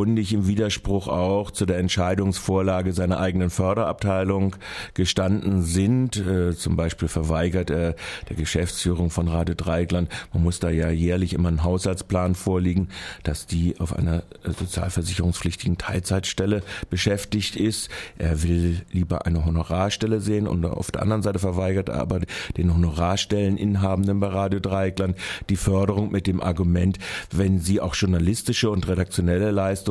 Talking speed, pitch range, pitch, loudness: 135 wpm, 85-100 Hz, 95 Hz, -24 LUFS